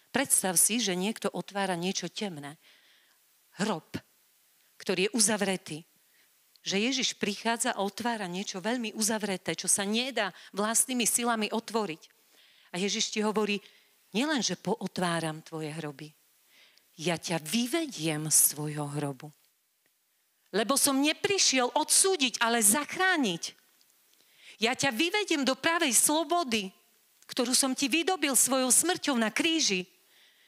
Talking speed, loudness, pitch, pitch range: 115 wpm, -27 LUFS, 220 Hz, 185-265 Hz